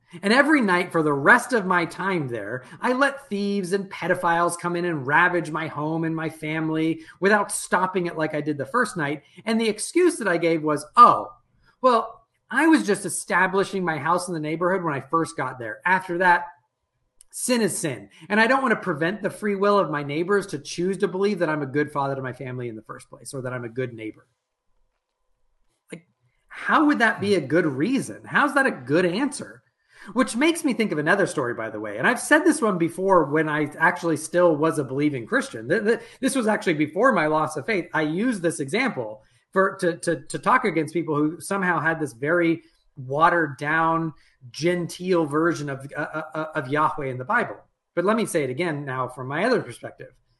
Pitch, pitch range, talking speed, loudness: 170 Hz, 150-200 Hz, 215 wpm, -23 LUFS